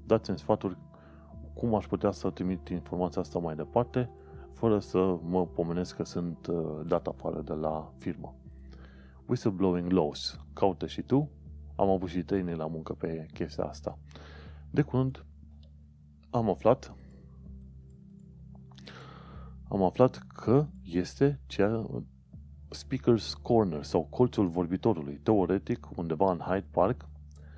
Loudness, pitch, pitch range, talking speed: -31 LUFS, 80 Hz, 75-95 Hz, 120 wpm